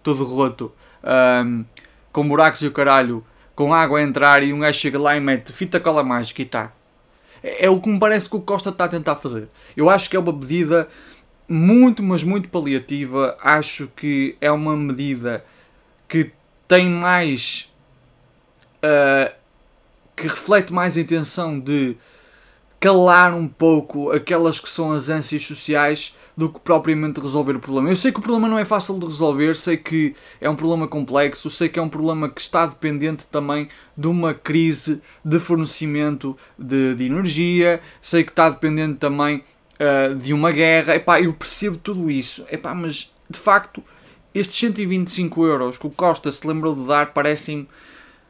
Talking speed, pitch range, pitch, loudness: 175 wpm, 145-170 Hz, 155 Hz, -19 LUFS